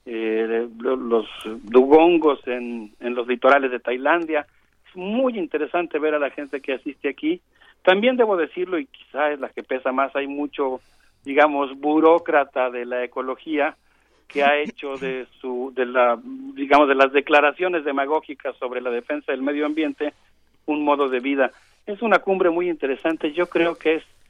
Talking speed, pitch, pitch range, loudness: 165 wpm, 145 Hz, 130-155 Hz, -21 LUFS